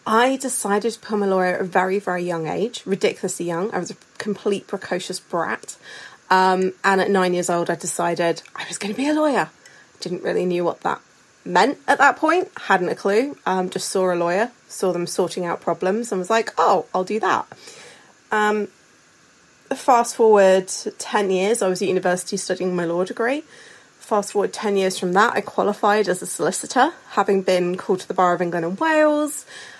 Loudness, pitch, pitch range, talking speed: -21 LUFS, 195 Hz, 185-220 Hz, 195 wpm